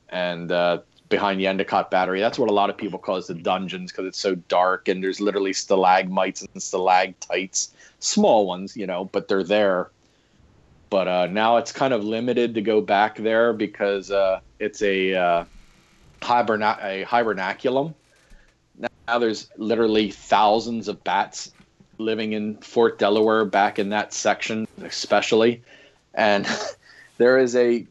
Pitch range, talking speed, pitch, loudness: 95-110 Hz, 155 wpm, 105 Hz, -22 LUFS